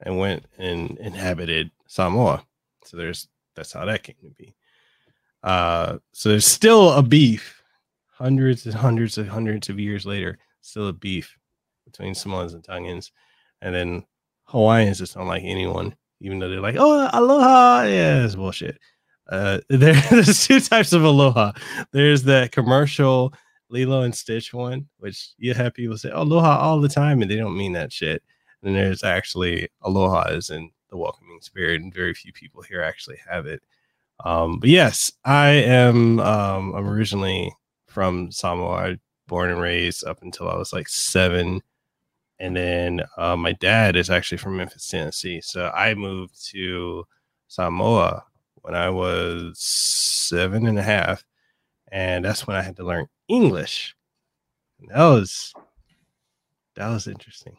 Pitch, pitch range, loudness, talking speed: 100 Hz, 90-125 Hz, -19 LUFS, 160 wpm